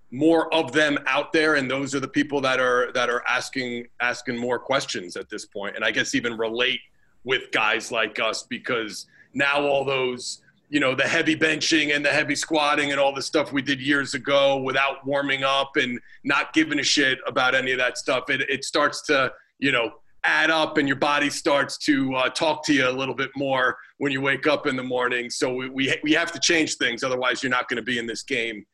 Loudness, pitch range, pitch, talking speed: -22 LUFS, 125-150 Hz, 140 Hz, 230 wpm